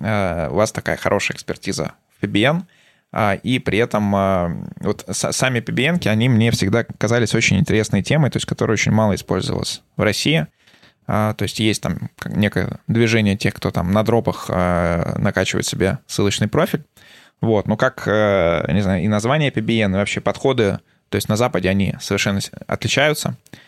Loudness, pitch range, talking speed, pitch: -19 LUFS, 100-115 Hz, 155 wpm, 105 Hz